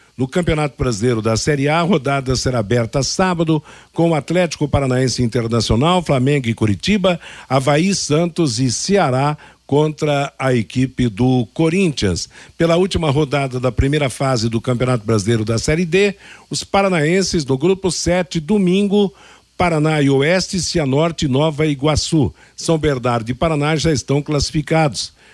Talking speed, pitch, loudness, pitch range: 140 wpm, 145 Hz, -17 LUFS, 125-170 Hz